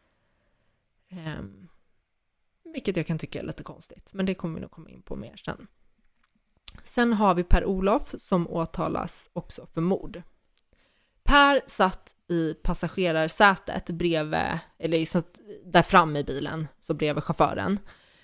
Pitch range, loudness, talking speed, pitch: 165-195 Hz, -25 LUFS, 130 wpm, 175 Hz